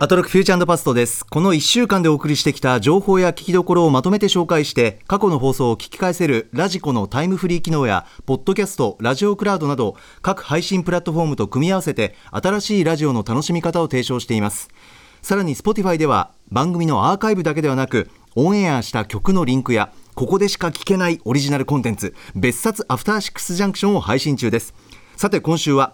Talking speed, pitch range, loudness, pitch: 475 characters per minute, 130-190 Hz, -18 LUFS, 155 Hz